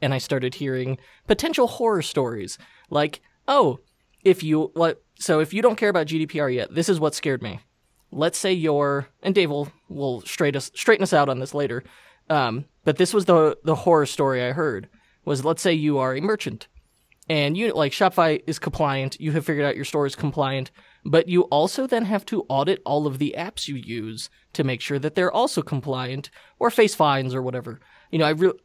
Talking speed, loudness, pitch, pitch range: 210 wpm, -23 LUFS, 155 Hz, 140-180 Hz